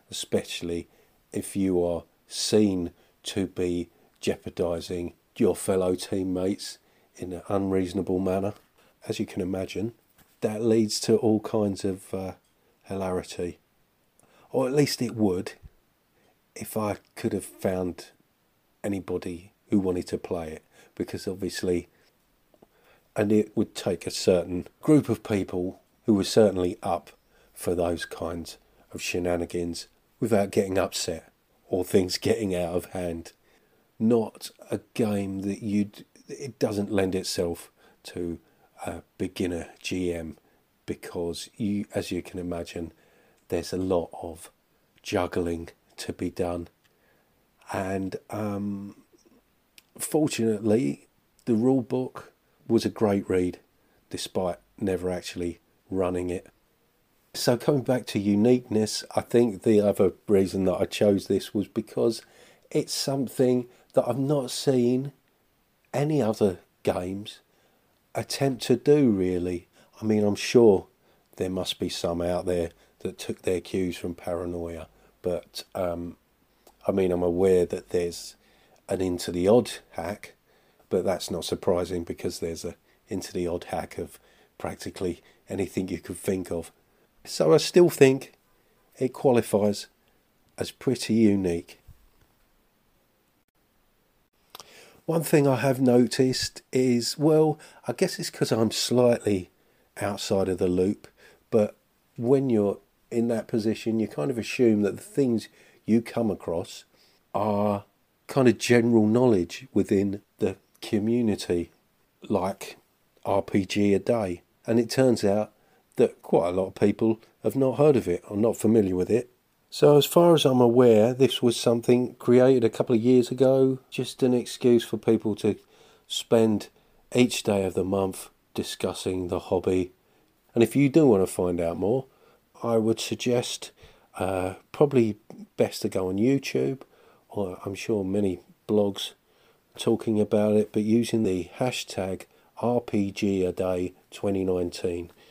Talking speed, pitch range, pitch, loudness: 135 wpm, 90-120 Hz, 105 Hz, -26 LUFS